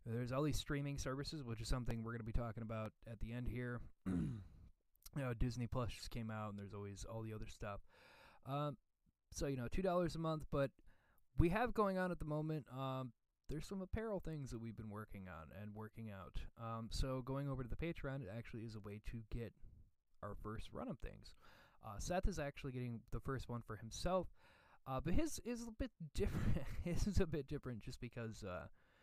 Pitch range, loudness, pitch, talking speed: 110-140 Hz, -45 LUFS, 120 Hz, 215 wpm